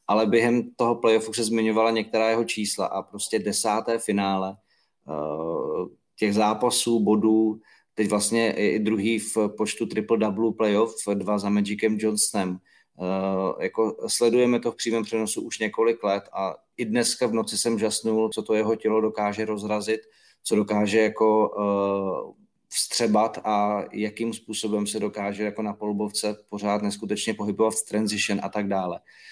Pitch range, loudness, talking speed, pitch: 105-110 Hz, -24 LUFS, 145 wpm, 110 Hz